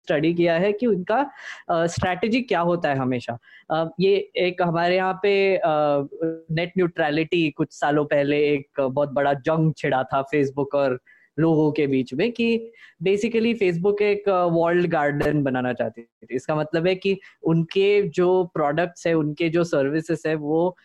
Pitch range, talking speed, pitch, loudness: 145-185 Hz, 165 wpm, 165 Hz, -22 LUFS